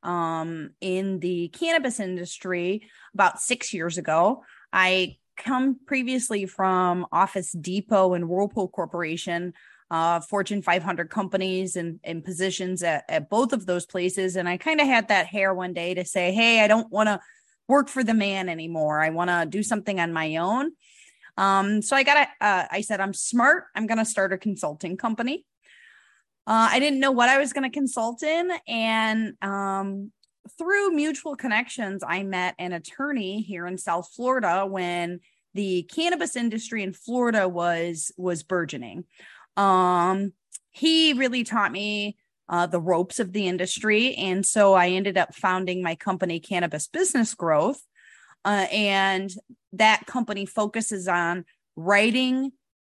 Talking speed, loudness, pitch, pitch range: 155 wpm, -24 LUFS, 195 Hz, 180-230 Hz